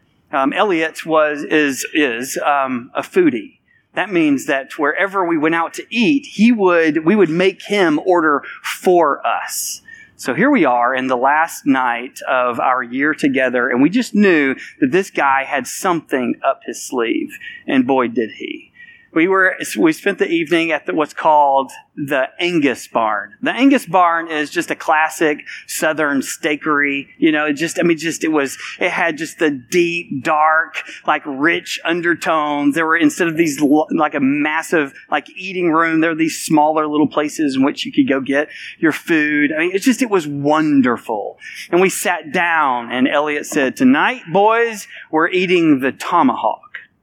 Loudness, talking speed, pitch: -16 LUFS, 175 wpm, 170 Hz